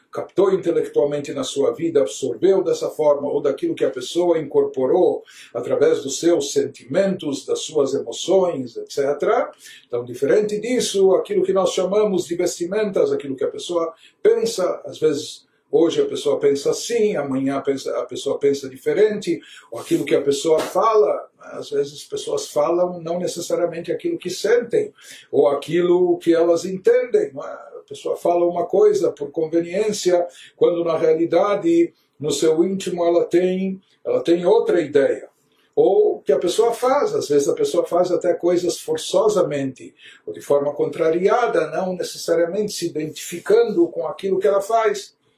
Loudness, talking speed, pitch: -20 LUFS, 150 wpm, 215 Hz